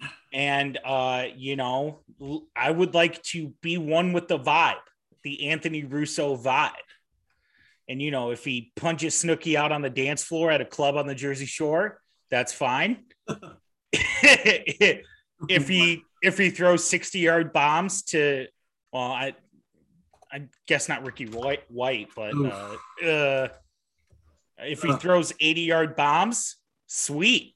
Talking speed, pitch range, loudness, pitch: 140 wpm, 140-170 Hz, -24 LUFS, 150 Hz